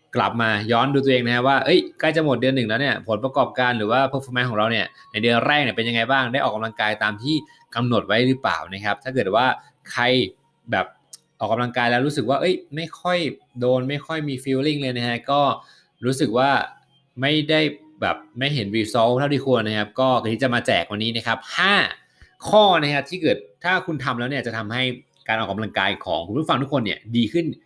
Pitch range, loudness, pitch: 115-145 Hz, -21 LUFS, 130 Hz